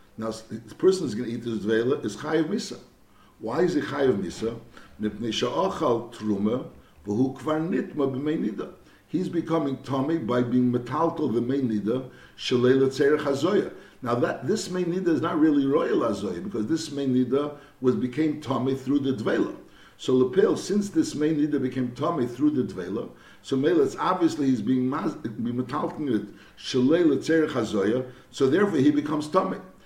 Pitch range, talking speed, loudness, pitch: 120-160 Hz, 155 wpm, -25 LUFS, 135 Hz